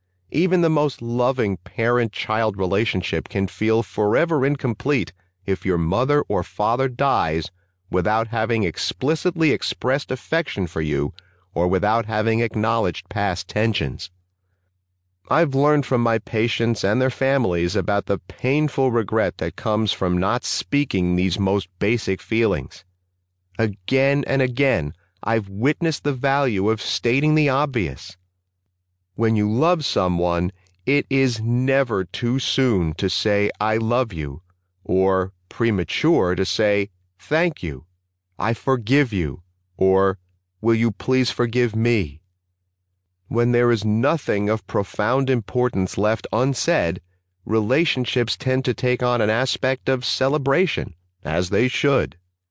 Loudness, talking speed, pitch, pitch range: -21 LUFS, 125 wpm, 110 Hz, 90-125 Hz